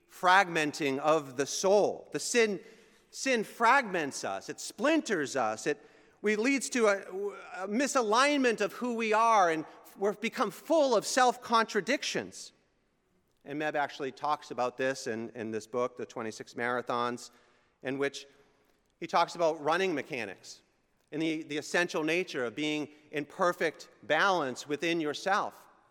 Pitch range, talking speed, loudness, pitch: 140-220 Hz, 140 wpm, -30 LUFS, 160 Hz